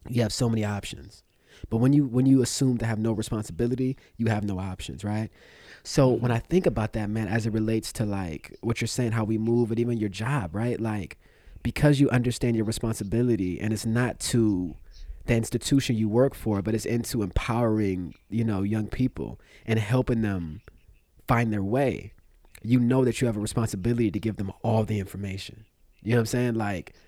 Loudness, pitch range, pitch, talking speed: -26 LUFS, 105-120 Hz, 110 Hz, 200 wpm